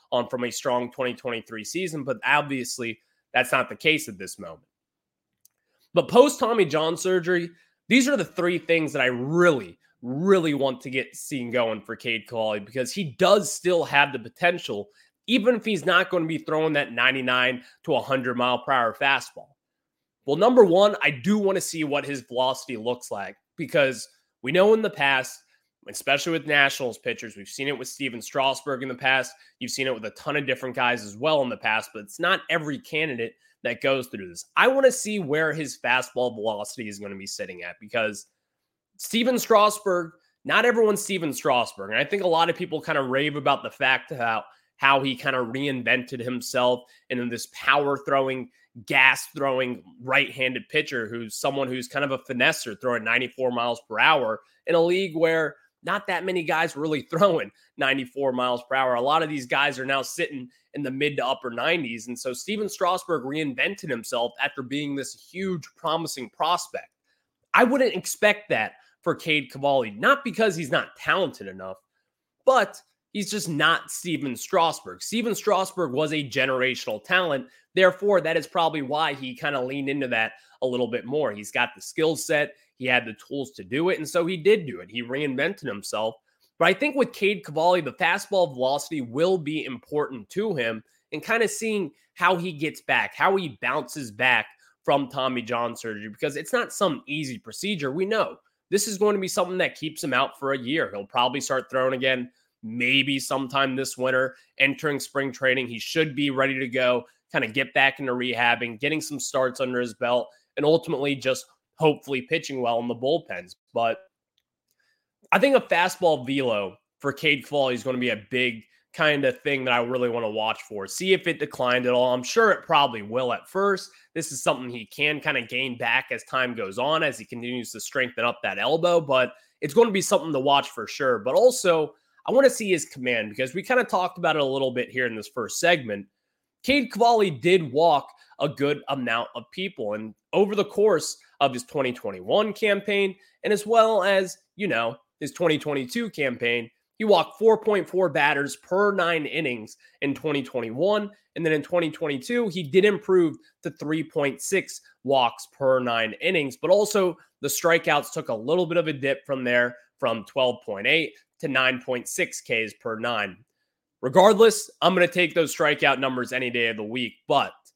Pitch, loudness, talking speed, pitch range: 140 Hz, -24 LUFS, 195 wpm, 125-180 Hz